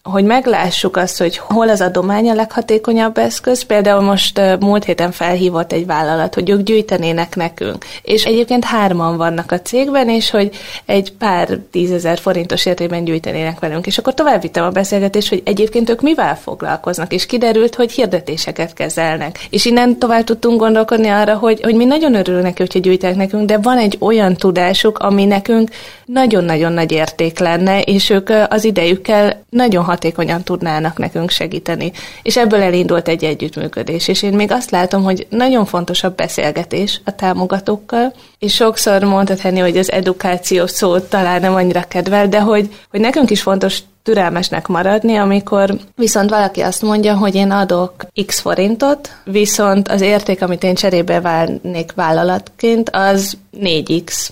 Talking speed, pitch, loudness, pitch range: 160 wpm, 195 Hz, -14 LUFS, 180-220 Hz